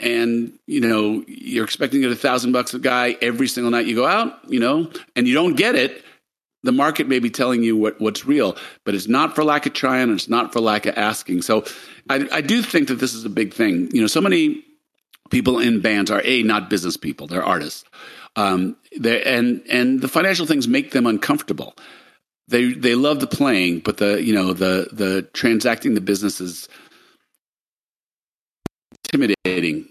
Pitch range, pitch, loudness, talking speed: 105-145 Hz, 125 Hz, -19 LUFS, 195 wpm